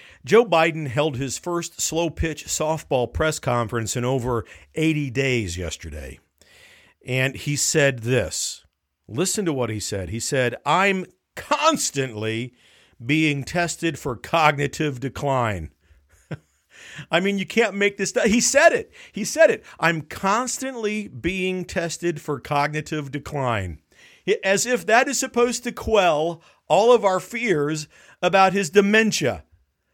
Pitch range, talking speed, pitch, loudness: 125-195 Hz, 135 wpm, 155 Hz, -22 LUFS